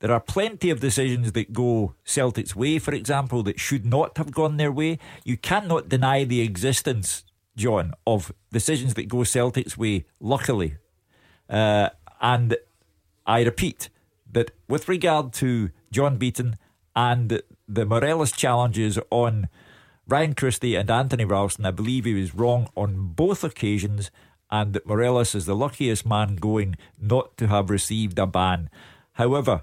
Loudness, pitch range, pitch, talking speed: -24 LUFS, 105-130 Hz, 115 Hz, 150 wpm